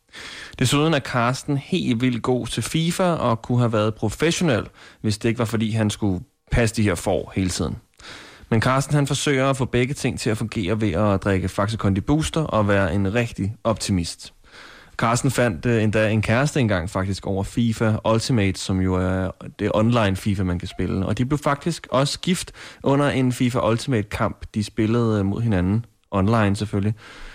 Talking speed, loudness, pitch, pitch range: 180 wpm, -22 LUFS, 110 Hz, 100-125 Hz